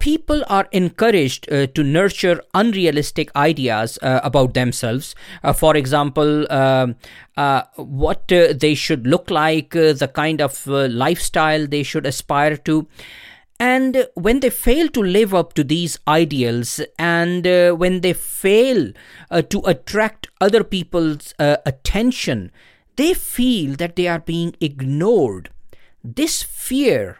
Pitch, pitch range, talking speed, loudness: 160 Hz, 145-195 Hz, 140 wpm, -17 LUFS